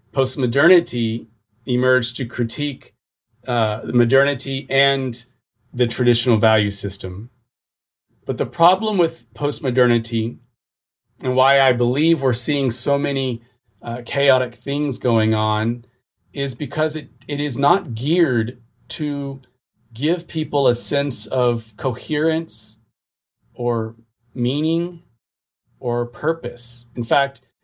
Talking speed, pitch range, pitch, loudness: 110 wpm, 115-140 Hz, 125 Hz, -20 LUFS